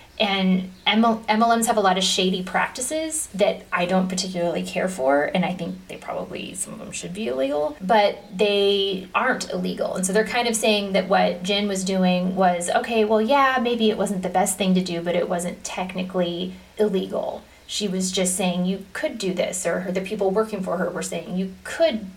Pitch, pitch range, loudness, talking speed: 190 Hz, 185-215 Hz, -22 LUFS, 205 wpm